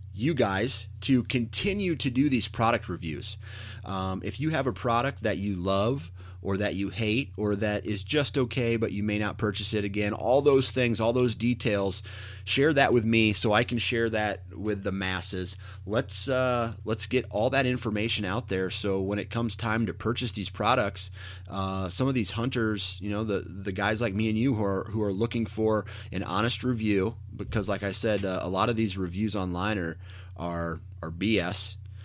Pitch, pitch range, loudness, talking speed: 105 Hz, 95-115 Hz, -28 LUFS, 200 wpm